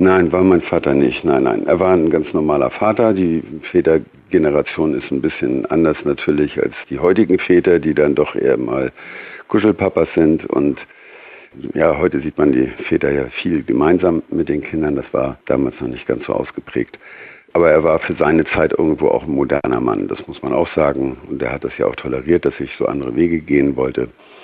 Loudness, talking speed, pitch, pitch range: -16 LUFS, 200 wpm, 80 Hz, 70-90 Hz